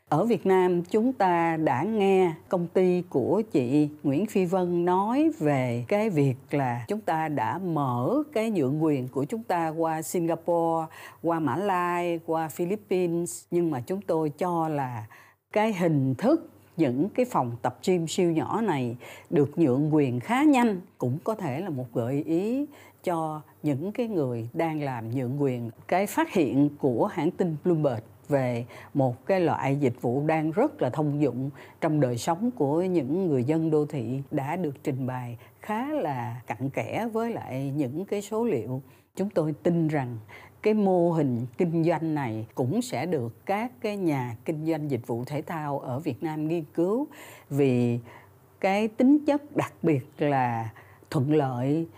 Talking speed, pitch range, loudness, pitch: 175 wpm, 130-180 Hz, -27 LUFS, 155 Hz